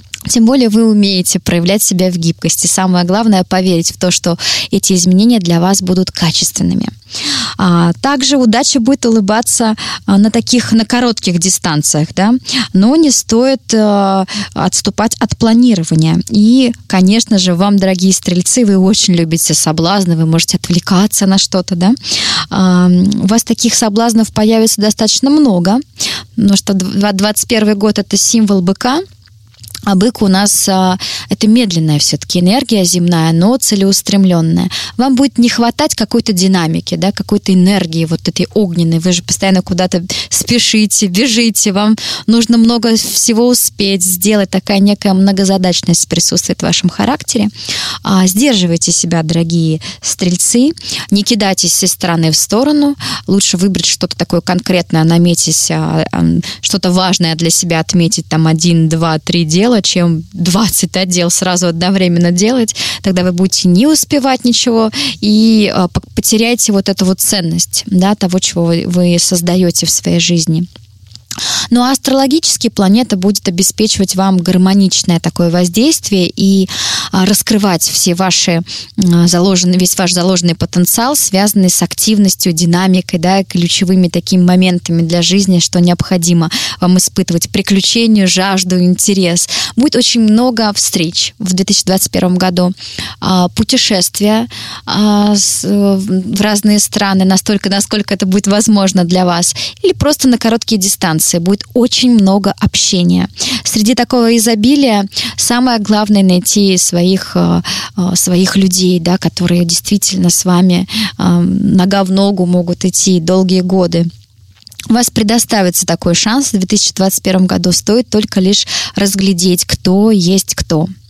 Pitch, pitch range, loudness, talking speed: 190 Hz, 175-215 Hz, -10 LUFS, 130 wpm